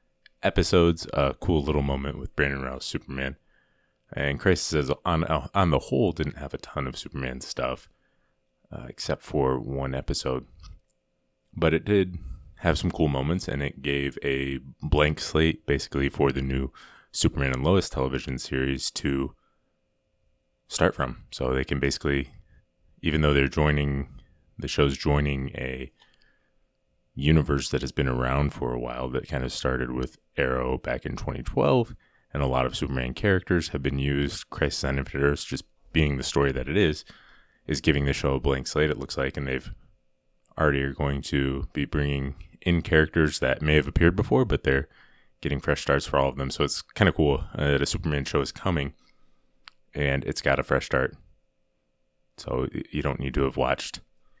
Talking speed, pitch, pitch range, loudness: 175 wpm, 70 Hz, 65-80 Hz, -26 LUFS